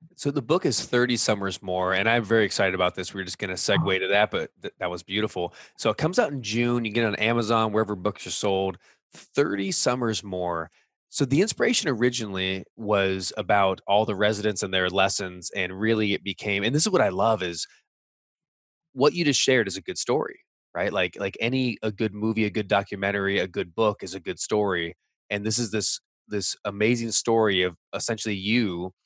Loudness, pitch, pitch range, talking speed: -25 LUFS, 105 Hz, 95-115 Hz, 215 wpm